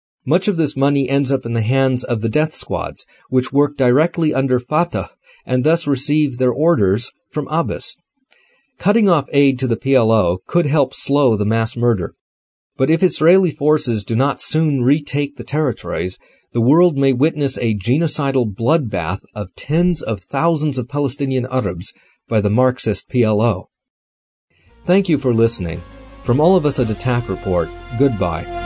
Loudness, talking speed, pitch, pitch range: -18 LUFS, 160 wpm, 130 Hz, 115-150 Hz